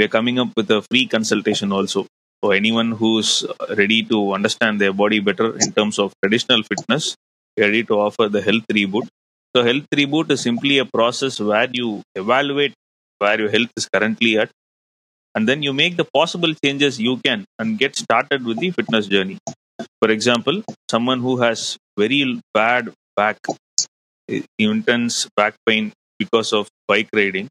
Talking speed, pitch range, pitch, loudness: 170 wpm, 105-135 Hz, 115 Hz, -18 LUFS